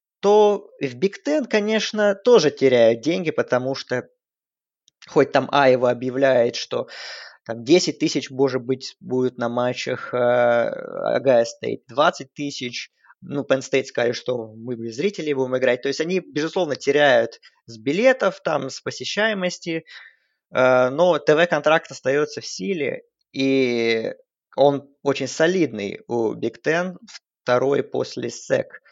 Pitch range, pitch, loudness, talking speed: 125-180 Hz, 140 Hz, -21 LUFS, 130 wpm